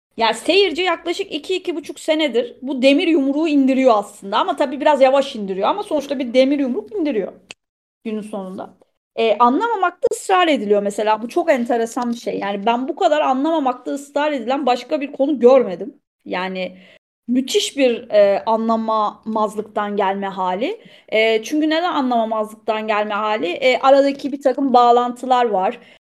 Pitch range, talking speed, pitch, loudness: 220-305 Hz, 150 wpm, 260 Hz, -18 LUFS